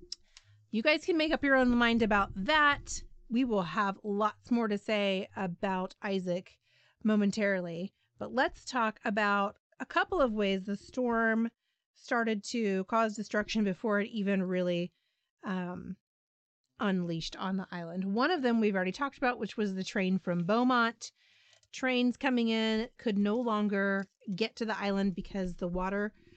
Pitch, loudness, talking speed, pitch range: 210 Hz, -31 LUFS, 155 wpm, 190-230 Hz